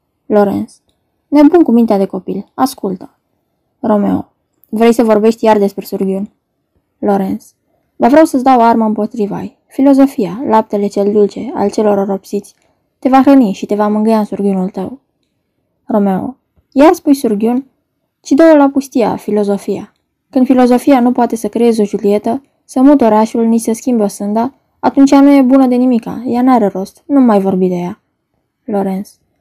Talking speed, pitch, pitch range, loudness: 160 wpm, 225 Hz, 205-265 Hz, -11 LUFS